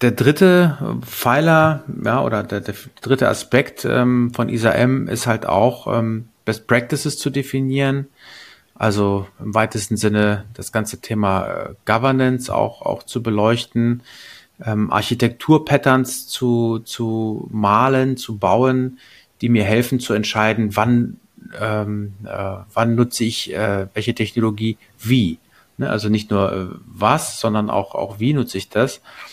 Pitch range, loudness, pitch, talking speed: 105-130 Hz, -19 LUFS, 115 Hz, 140 wpm